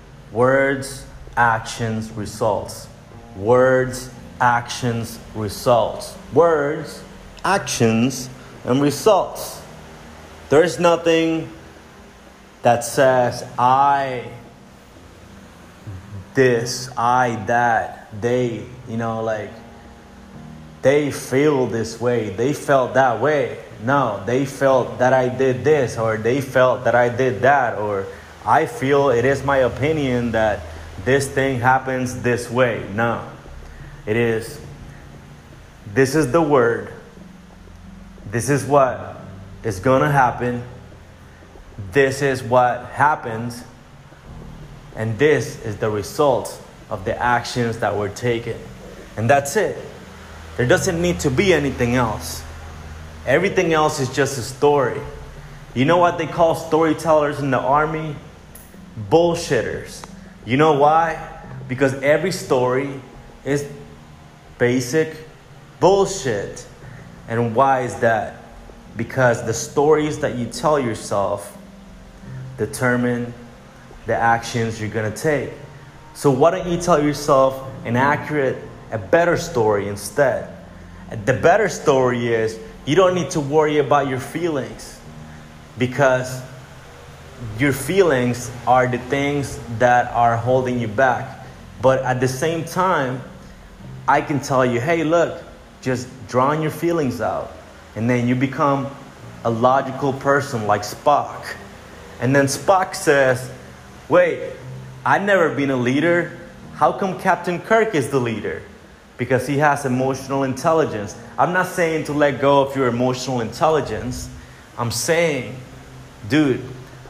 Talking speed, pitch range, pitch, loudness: 120 wpm, 115-140 Hz, 125 Hz, -19 LUFS